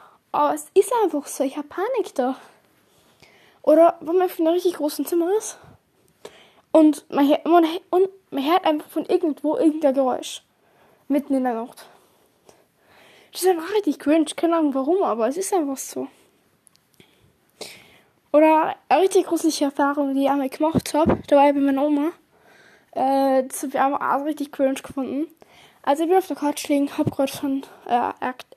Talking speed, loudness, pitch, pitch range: 170 wpm, -21 LUFS, 300 Hz, 280-340 Hz